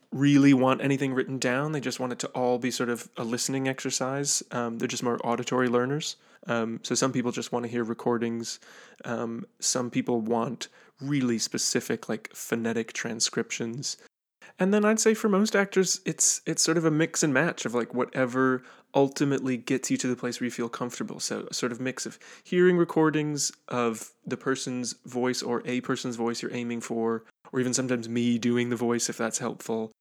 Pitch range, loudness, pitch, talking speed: 120-140 Hz, -27 LUFS, 125 Hz, 195 wpm